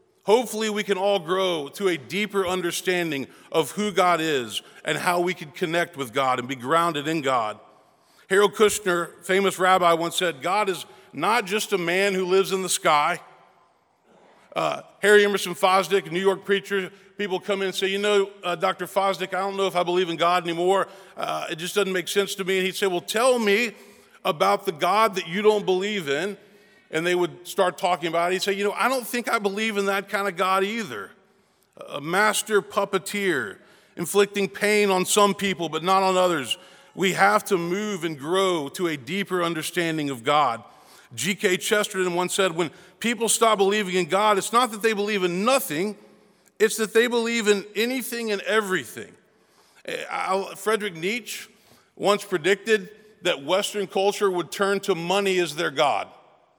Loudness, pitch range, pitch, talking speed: -23 LUFS, 180-205 Hz, 195 Hz, 185 wpm